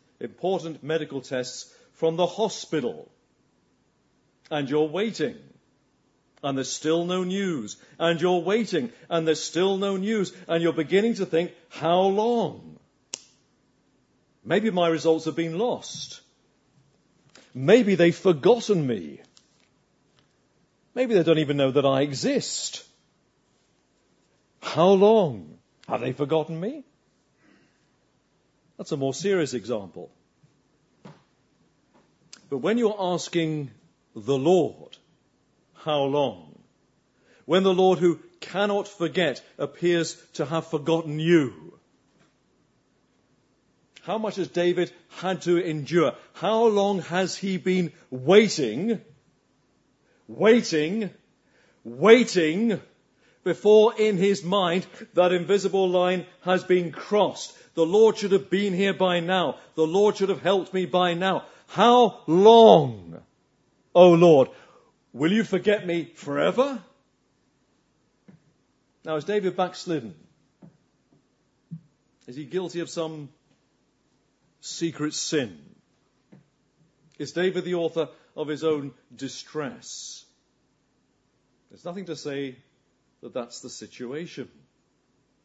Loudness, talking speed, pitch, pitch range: -23 LUFS, 110 wpm, 175 Hz, 155-195 Hz